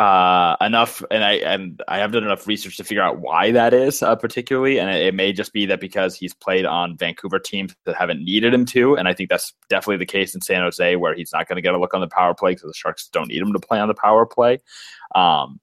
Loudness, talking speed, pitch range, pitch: -19 LUFS, 275 wpm, 95-120 Hz, 105 Hz